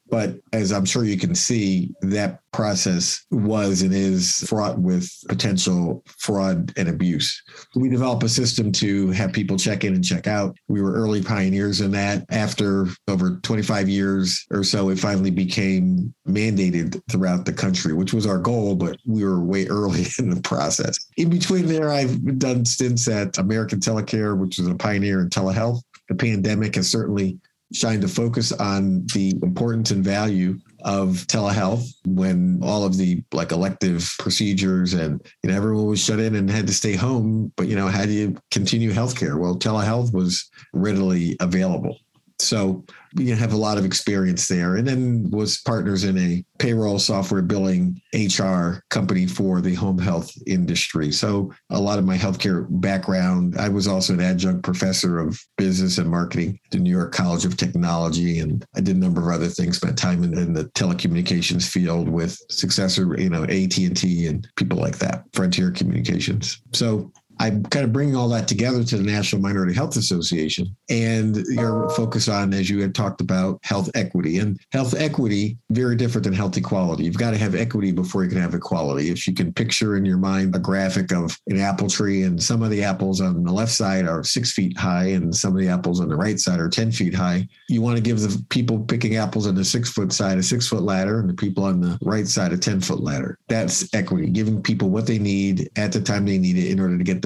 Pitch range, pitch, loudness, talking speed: 95-110 Hz, 100 Hz, -21 LUFS, 200 wpm